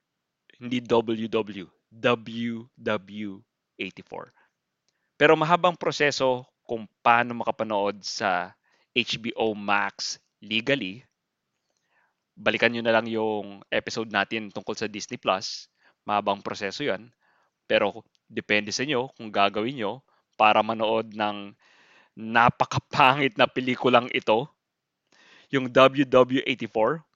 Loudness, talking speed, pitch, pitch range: -25 LUFS, 95 wpm, 115 Hz, 105-125 Hz